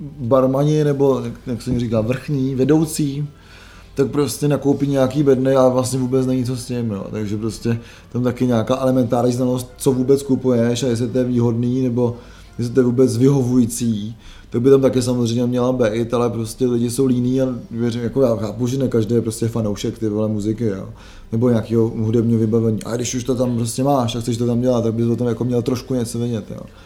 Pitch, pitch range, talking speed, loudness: 120 Hz, 115-130 Hz, 210 wpm, -19 LUFS